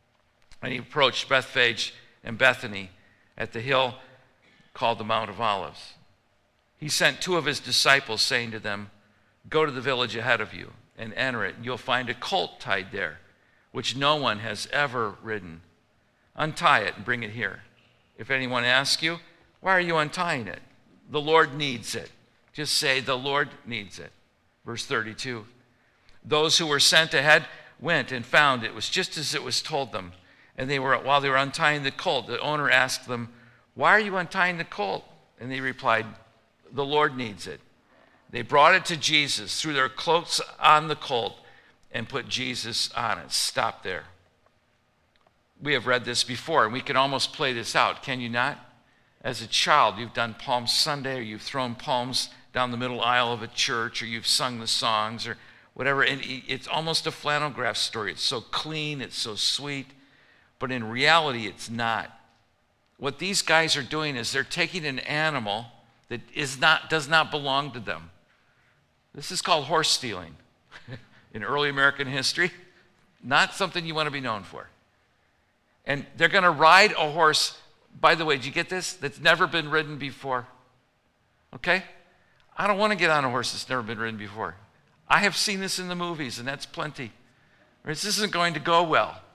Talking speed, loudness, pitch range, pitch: 185 wpm, -24 LUFS, 115-155 Hz, 130 Hz